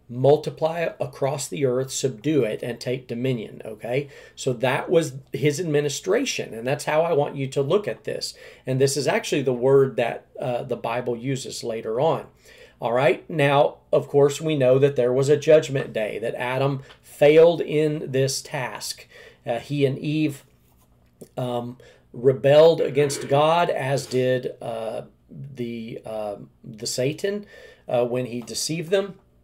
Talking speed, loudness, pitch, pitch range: 155 wpm, -23 LUFS, 135 Hz, 125-150 Hz